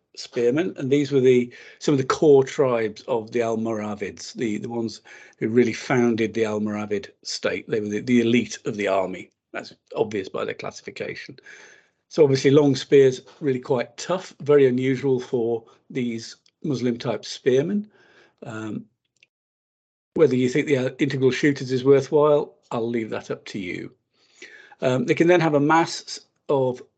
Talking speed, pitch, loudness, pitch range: 160 wpm, 130 Hz, -22 LUFS, 115-140 Hz